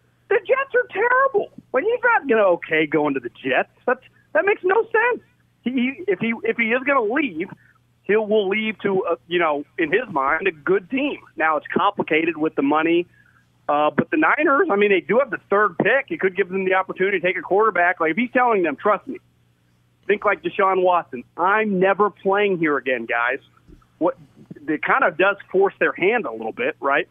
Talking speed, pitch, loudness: 210 wpm, 200 Hz, -20 LUFS